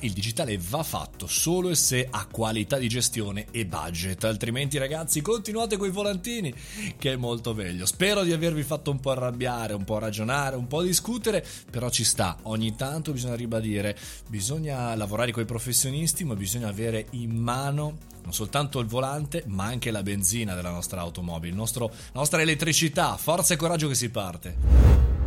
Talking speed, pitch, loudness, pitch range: 175 wpm, 120 Hz, -26 LUFS, 110-150 Hz